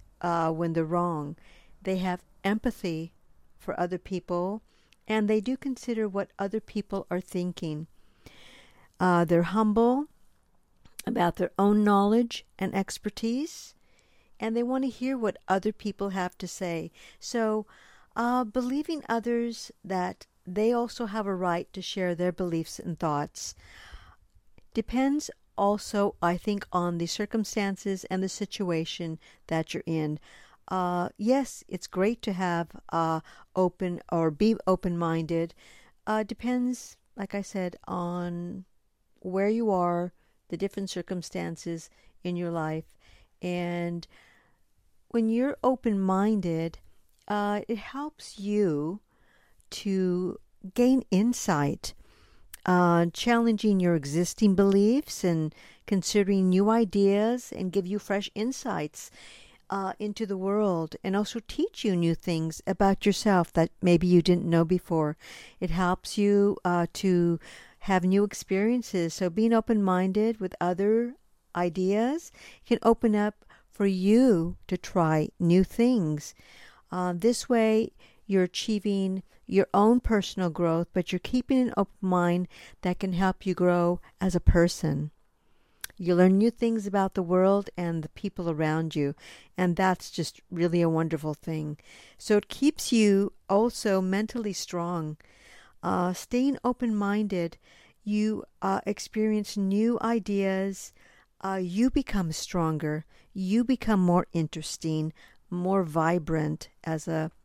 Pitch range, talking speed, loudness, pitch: 175-215 Hz, 130 wpm, -28 LUFS, 190 Hz